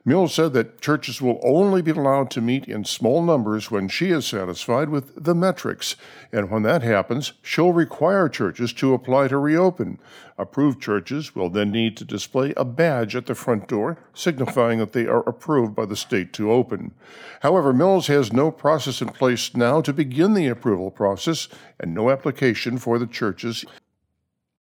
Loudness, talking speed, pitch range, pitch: -21 LUFS, 180 wpm, 110-150 Hz, 130 Hz